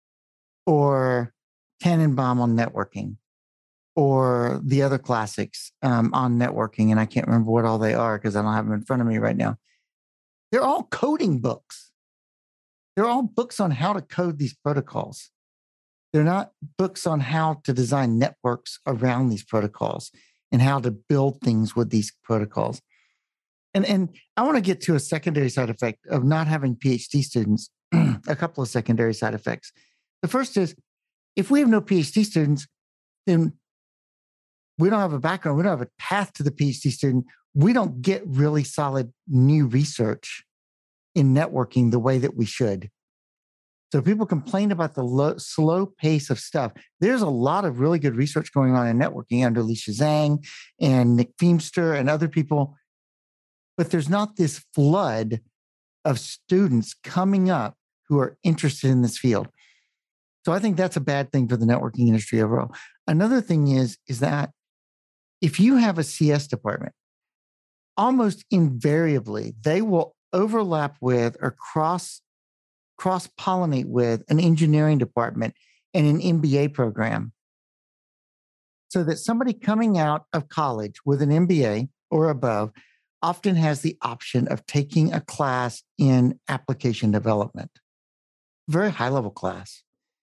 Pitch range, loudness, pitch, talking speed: 120-165 Hz, -23 LUFS, 140 Hz, 155 wpm